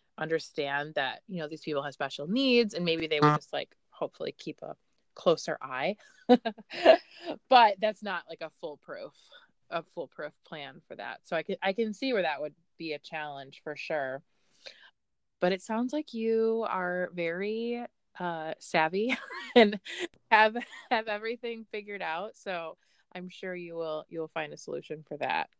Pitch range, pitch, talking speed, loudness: 160-225 Hz, 185 Hz, 165 wpm, -30 LUFS